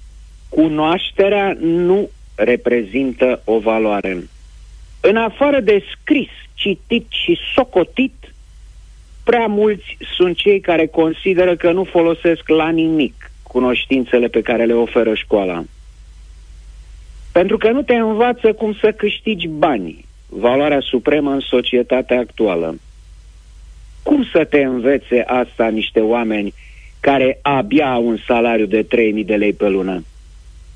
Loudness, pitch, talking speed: -16 LUFS, 125 Hz, 120 wpm